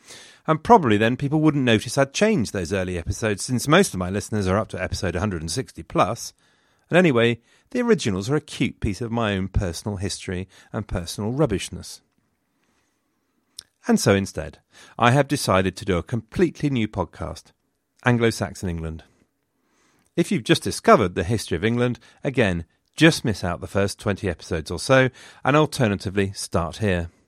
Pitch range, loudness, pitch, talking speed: 95-130 Hz, -22 LUFS, 105 Hz, 165 wpm